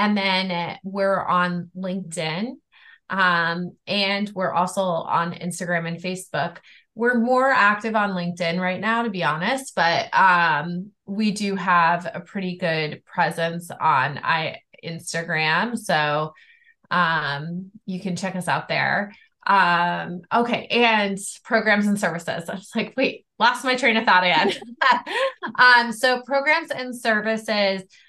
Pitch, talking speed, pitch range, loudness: 195 Hz, 135 wpm, 175-225 Hz, -21 LUFS